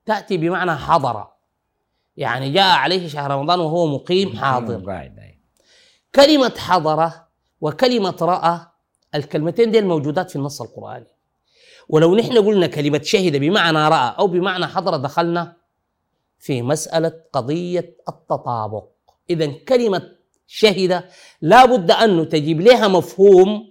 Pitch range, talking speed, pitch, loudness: 155-195 Hz, 115 wpm, 170 Hz, -17 LUFS